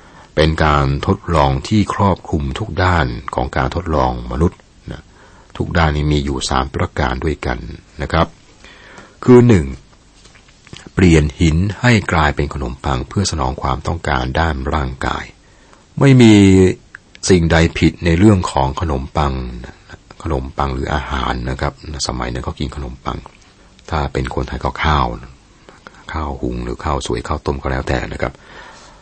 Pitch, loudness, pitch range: 75 Hz, -16 LUFS, 65-85 Hz